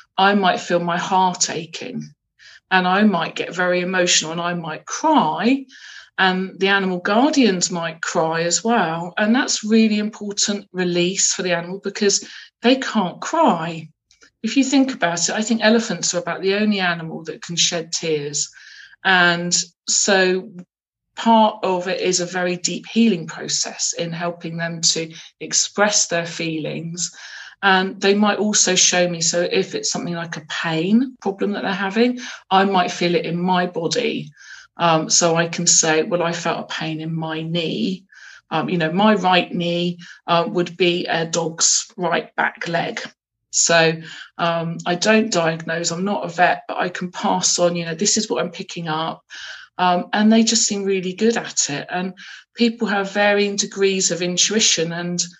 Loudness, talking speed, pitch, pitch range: -19 LUFS, 175 wpm, 180 Hz, 170-205 Hz